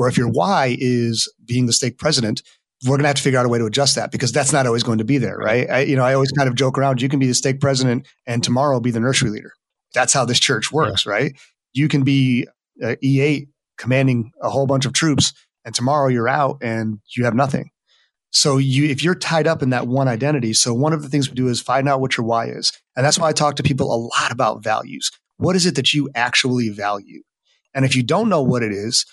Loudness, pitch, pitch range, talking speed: -18 LUFS, 130 Hz, 120-140 Hz, 260 wpm